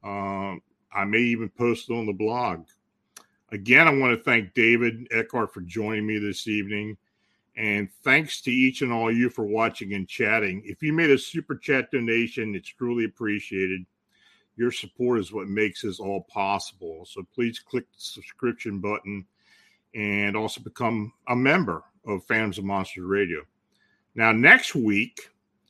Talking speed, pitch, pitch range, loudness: 165 wpm, 110 Hz, 100-120 Hz, -24 LUFS